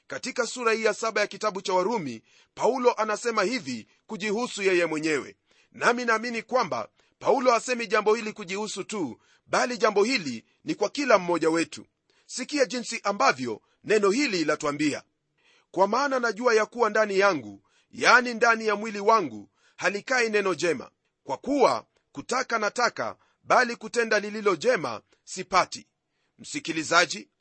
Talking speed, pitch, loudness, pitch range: 140 wpm, 220 Hz, -25 LUFS, 200-245 Hz